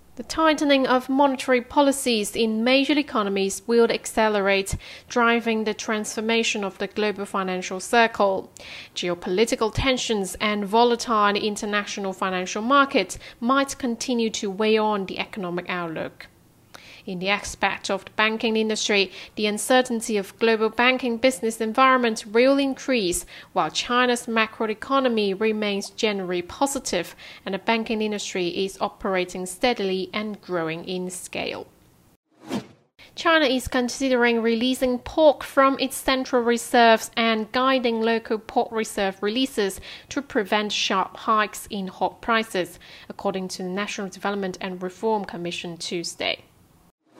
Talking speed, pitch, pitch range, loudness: 125 wpm, 220 Hz, 195-245 Hz, -23 LUFS